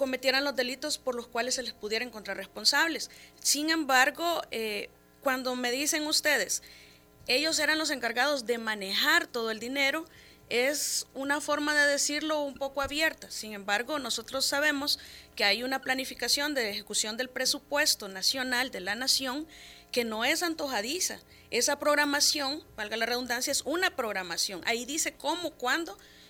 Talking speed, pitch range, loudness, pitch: 155 wpm, 230-295 Hz, -28 LUFS, 265 Hz